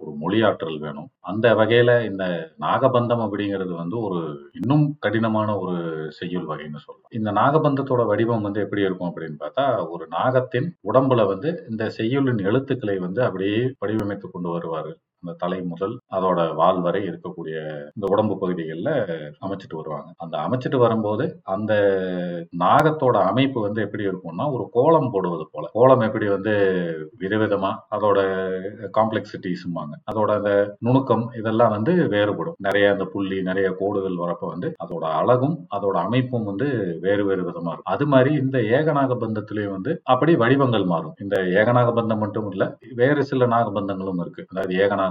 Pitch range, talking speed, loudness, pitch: 95-120 Hz, 145 wpm, -22 LUFS, 105 Hz